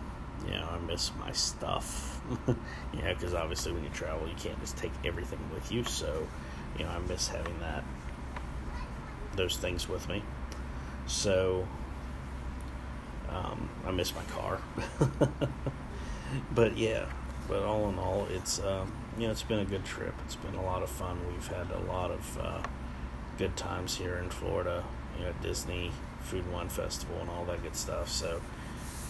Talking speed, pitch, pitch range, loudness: 170 wpm, 80 Hz, 65-90 Hz, -35 LUFS